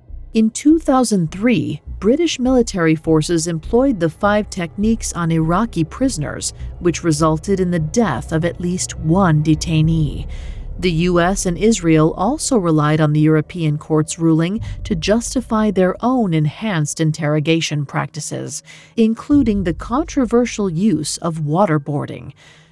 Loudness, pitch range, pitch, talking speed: -17 LUFS, 155-215 Hz, 170 Hz, 120 wpm